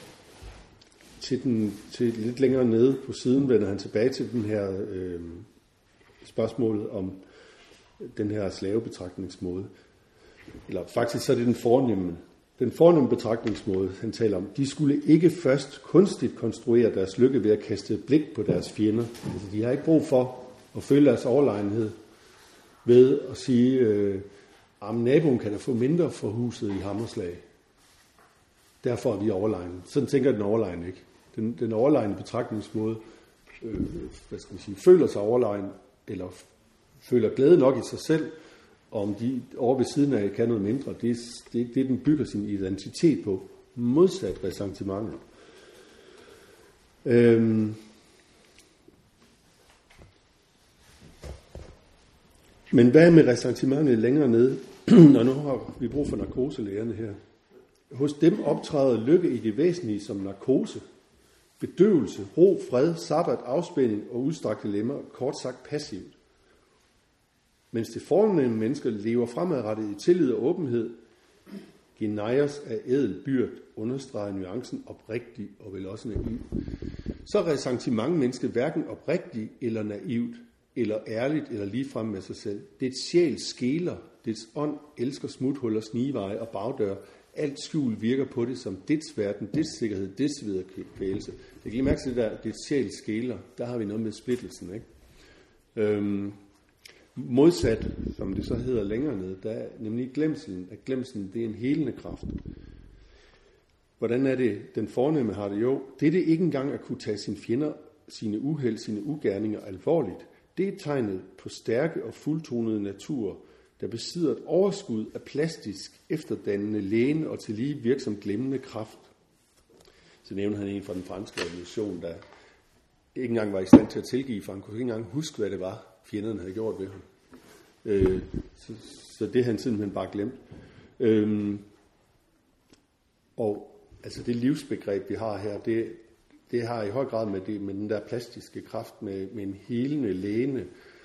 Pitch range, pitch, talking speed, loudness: 100-130 Hz, 115 Hz, 155 wpm, -26 LUFS